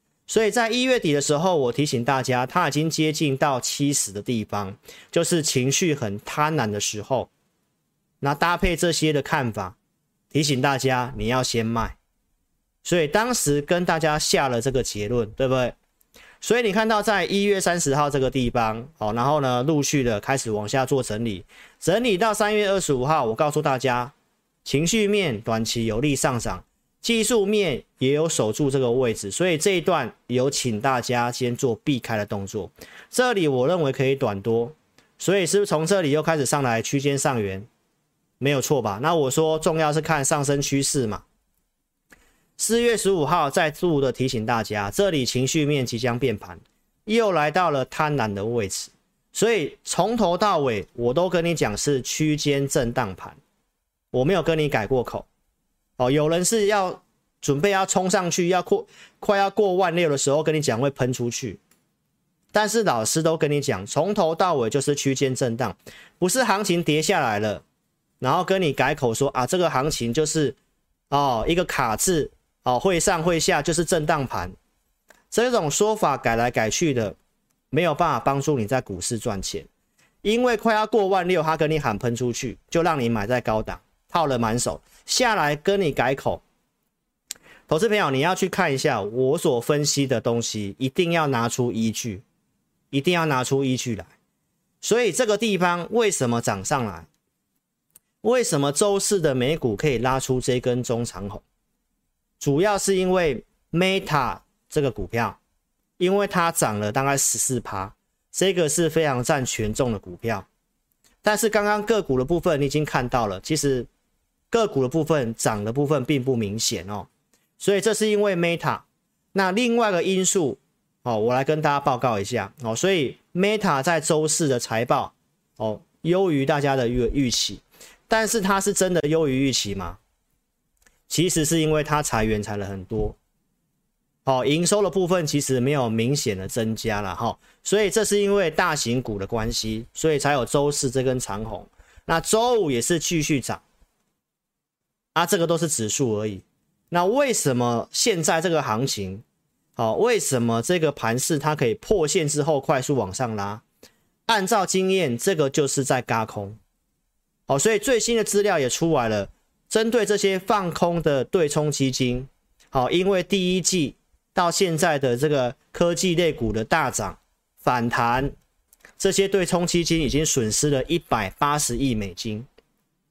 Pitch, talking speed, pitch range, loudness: 145 Hz, 255 characters per minute, 120-175 Hz, -22 LUFS